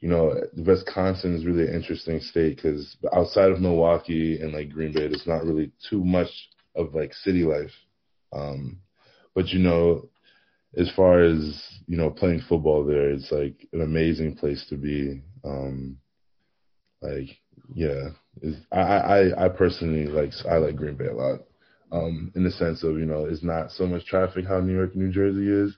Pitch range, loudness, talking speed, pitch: 75-90 Hz, -24 LUFS, 175 wpm, 80 Hz